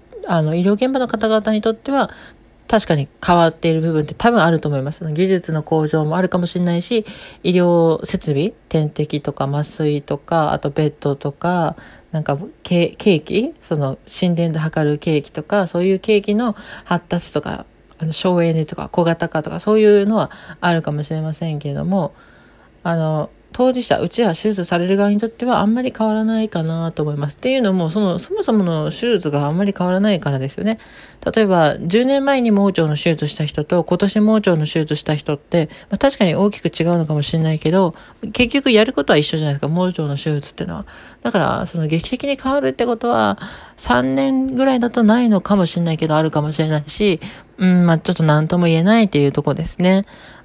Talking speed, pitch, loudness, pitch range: 395 characters per minute, 175 Hz, -18 LUFS, 155-210 Hz